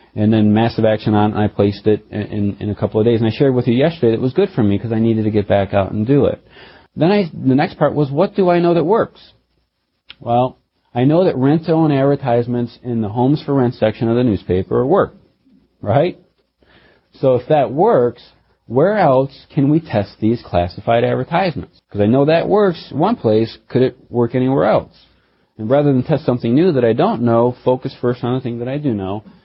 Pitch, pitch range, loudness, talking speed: 120 Hz, 110-140 Hz, -16 LUFS, 220 wpm